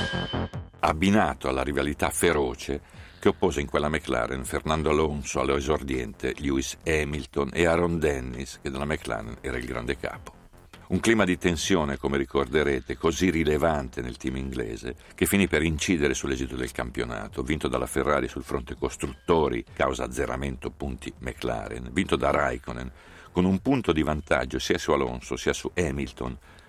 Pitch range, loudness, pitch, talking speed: 65-85 Hz, -27 LUFS, 75 Hz, 150 wpm